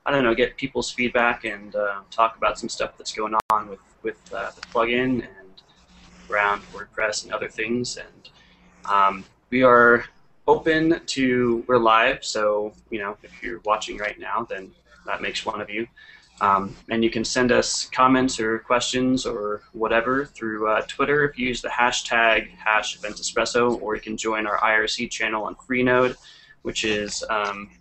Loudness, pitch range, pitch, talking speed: -22 LUFS, 110-125 Hz, 115 Hz, 175 wpm